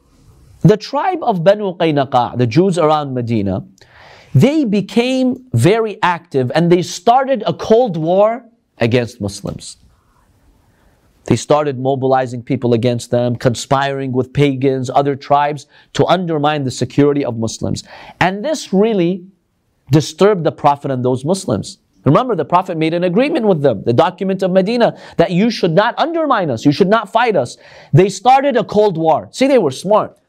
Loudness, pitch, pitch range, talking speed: -15 LUFS, 160 Hz, 130-200 Hz, 155 wpm